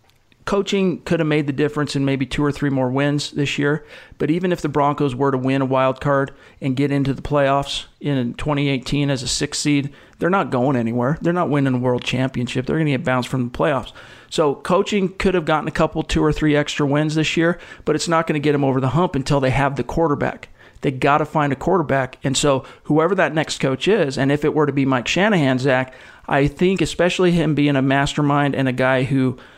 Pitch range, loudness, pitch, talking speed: 135-155 Hz, -19 LUFS, 145 Hz, 235 wpm